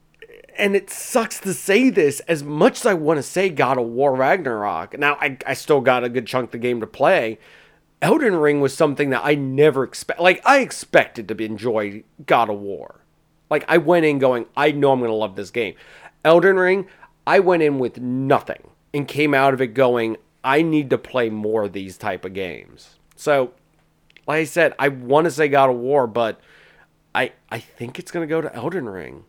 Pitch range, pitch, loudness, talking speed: 125-165 Hz, 145 Hz, -19 LUFS, 215 wpm